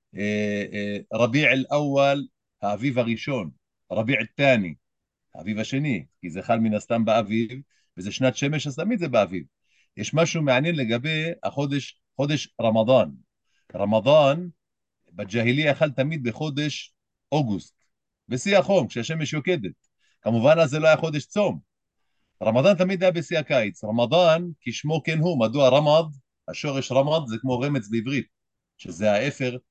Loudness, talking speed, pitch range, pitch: -23 LUFS, 130 wpm, 115-155 Hz, 135 Hz